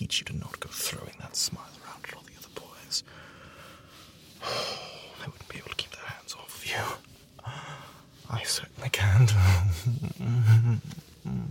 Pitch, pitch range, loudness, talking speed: 115 Hz, 100-125 Hz, -28 LUFS, 150 wpm